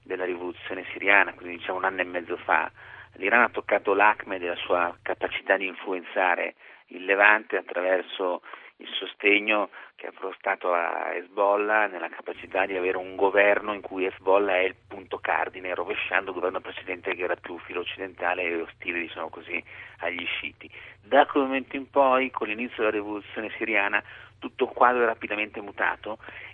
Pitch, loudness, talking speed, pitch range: 100 Hz, -26 LUFS, 165 wpm, 95-110 Hz